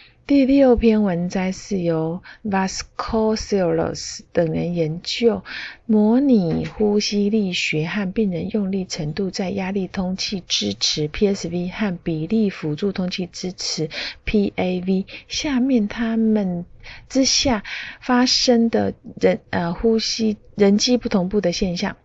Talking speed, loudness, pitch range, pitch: 210 characters per minute, -20 LUFS, 180-220 Hz, 200 Hz